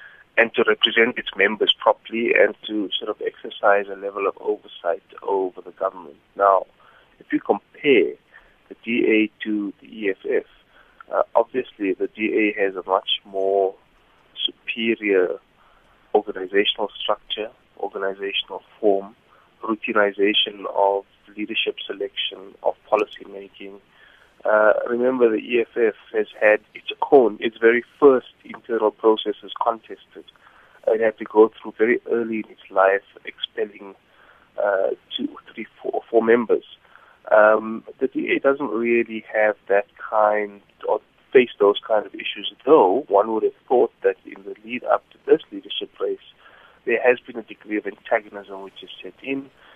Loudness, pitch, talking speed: -21 LUFS, 135 Hz, 140 wpm